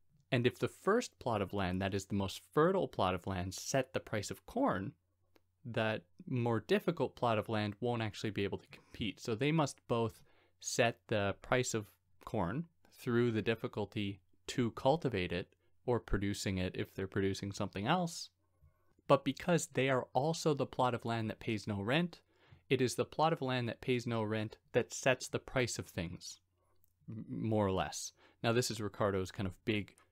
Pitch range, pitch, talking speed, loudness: 95-125 Hz, 110 Hz, 185 wpm, -36 LUFS